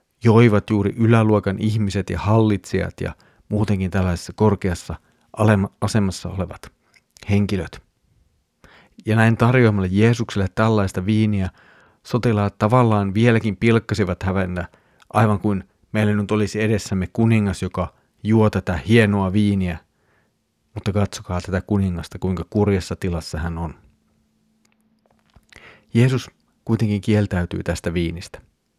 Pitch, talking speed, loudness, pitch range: 105 Hz, 105 wpm, -20 LUFS, 95-110 Hz